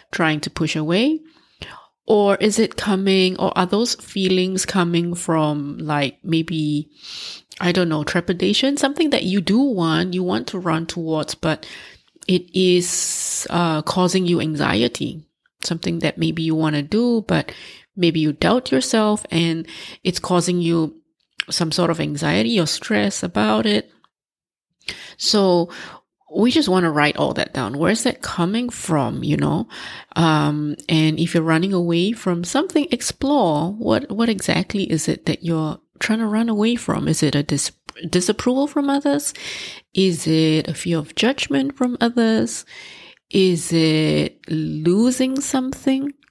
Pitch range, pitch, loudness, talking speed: 160-215 Hz, 175 Hz, -20 LUFS, 150 wpm